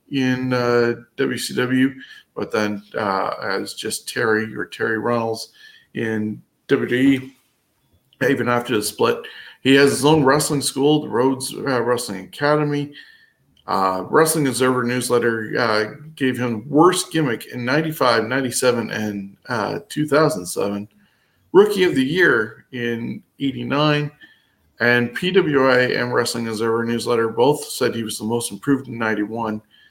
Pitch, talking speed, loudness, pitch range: 125 Hz, 130 wpm, -20 LUFS, 115-145 Hz